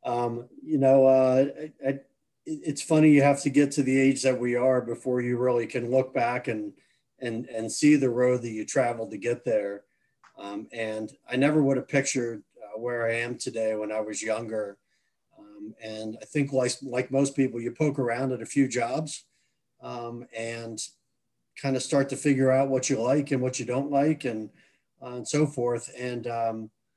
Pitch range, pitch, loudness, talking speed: 115-135 Hz, 125 Hz, -26 LUFS, 200 wpm